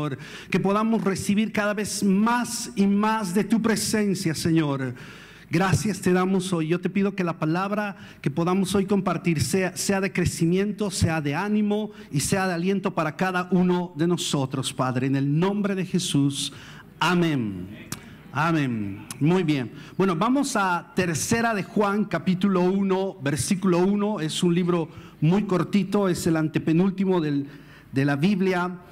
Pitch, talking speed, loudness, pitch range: 180 Hz, 155 wpm, -24 LUFS, 155-200 Hz